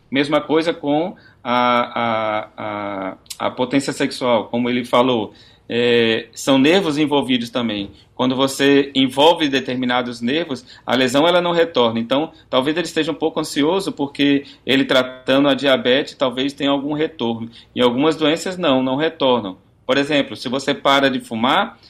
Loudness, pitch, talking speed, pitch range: -18 LUFS, 130 Hz, 155 wpm, 120-140 Hz